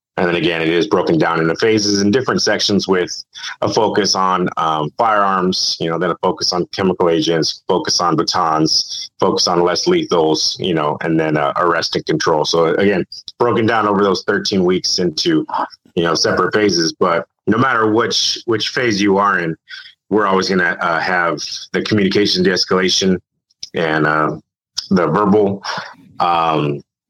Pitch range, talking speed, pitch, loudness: 80-100 Hz, 175 wpm, 90 Hz, -15 LUFS